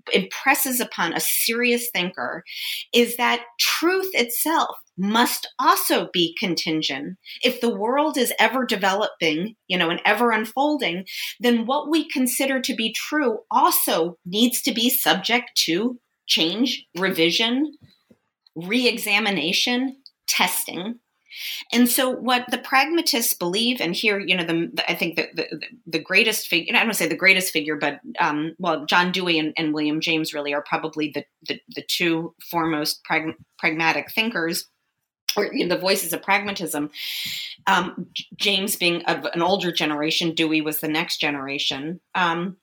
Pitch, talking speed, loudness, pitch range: 190 Hz, 150 wpm, -21 LUFS, 165-245 Hz